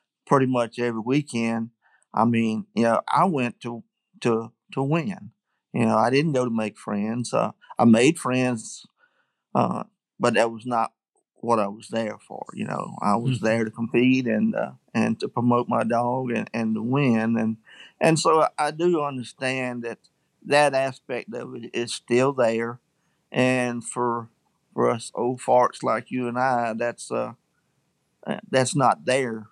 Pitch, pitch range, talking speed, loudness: 120 Hz, 115-130 Hz, 170 wpm, -24 LUFS